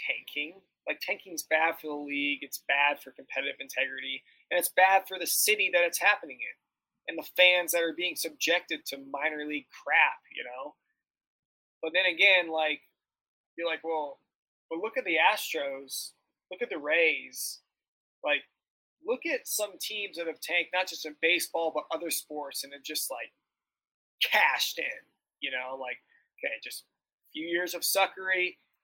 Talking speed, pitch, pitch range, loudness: 175 wpm, 165 Hz, 150-185 Hz, -28 LUFS